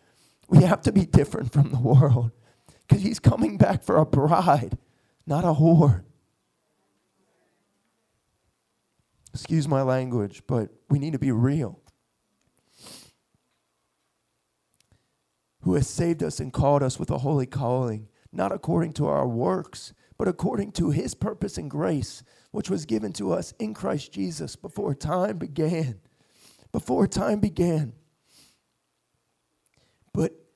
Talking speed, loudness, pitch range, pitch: 130 wpm, -24 LUFS, 125-165 Hz, 145 Hz